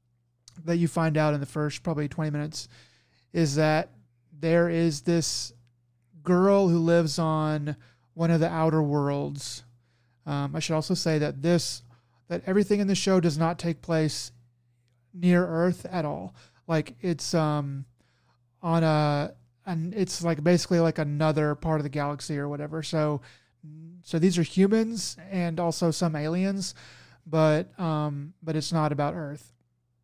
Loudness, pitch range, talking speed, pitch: -26 LUFS, 140-170 Hz, 155 wpm, 155 Hz